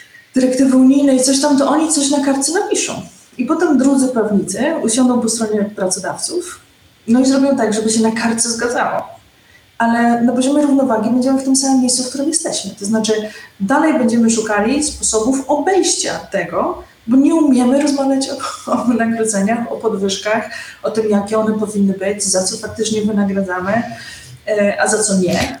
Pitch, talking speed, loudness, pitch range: 235 Hz, 165 wpm, -15 LUFS, 215-275 Hz